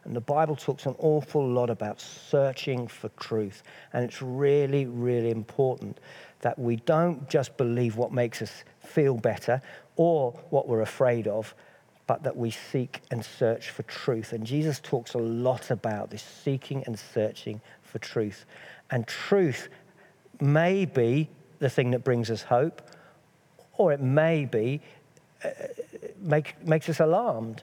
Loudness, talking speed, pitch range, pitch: -28 LUFS, 150 wpm, 120-155 Hz, 135 Hz